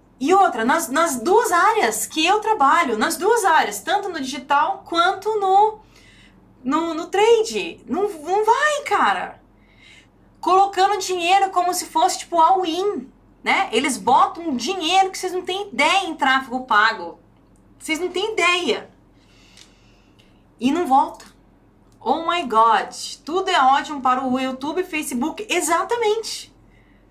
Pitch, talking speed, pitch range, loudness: 350 Hz, 135 wpm, 290-390 Hz, -19 LUFS